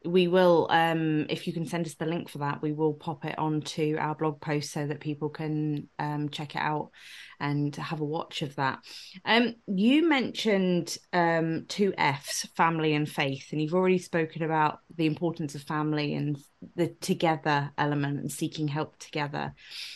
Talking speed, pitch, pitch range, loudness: 180 wpm, 155 Hz, 150-170 Hz, -28 LUFS